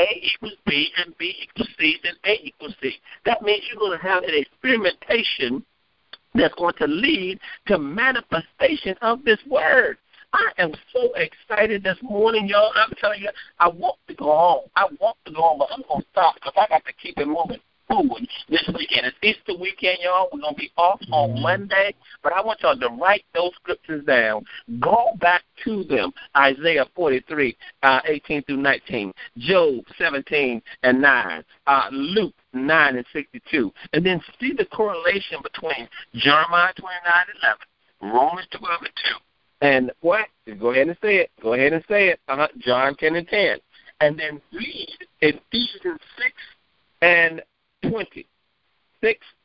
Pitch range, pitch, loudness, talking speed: 155-225 Hz, 185 Hz, -21 LUFS, 165 wpm